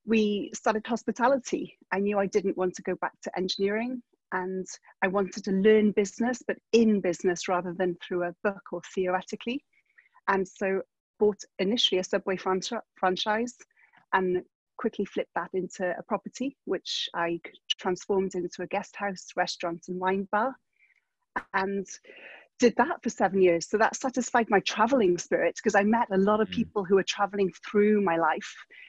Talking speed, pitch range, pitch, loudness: 165 wpm, 185-230 Hz, 200 Hz, -28 LUFS